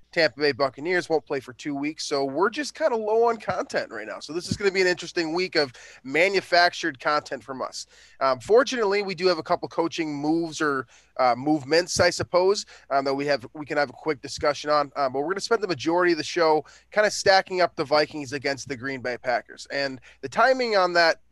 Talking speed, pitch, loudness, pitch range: 235 wpm, 155 Hz, -24 LUFS, 140-180 Hz